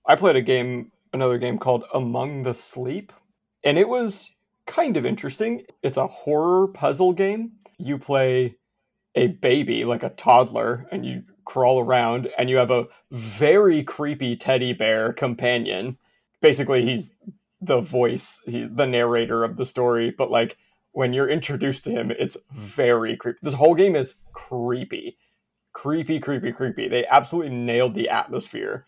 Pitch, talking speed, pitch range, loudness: 130 Hz, 155 wpm, 120-155 Hz, -22 LUFS